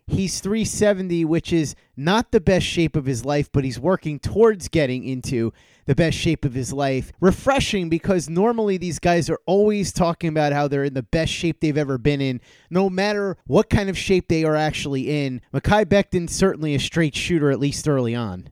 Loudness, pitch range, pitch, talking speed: -21 LUFS, 140-190 Hz, 165 Hz, 200 wpm